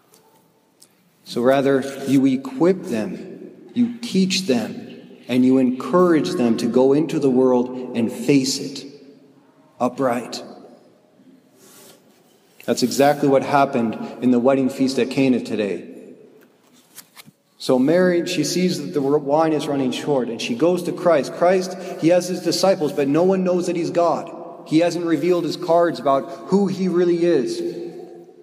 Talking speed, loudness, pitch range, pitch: 145 wpm, -19 LUFS, 135-180 Hz, 150 Hz